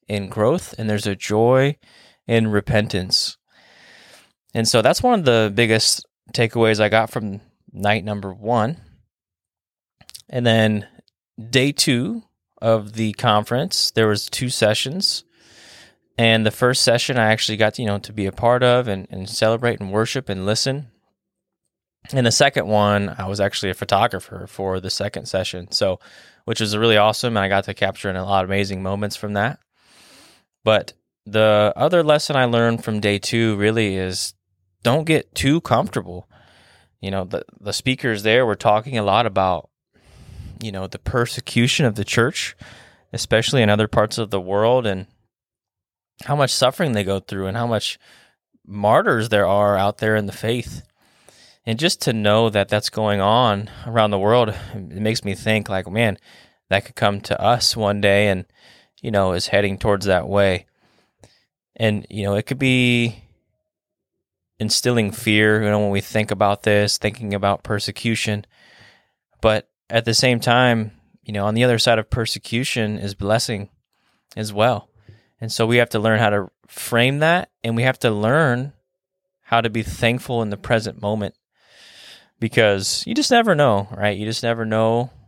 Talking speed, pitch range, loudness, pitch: 170 wpm, 100-120 Hz, -19 LUFS, 110 Hz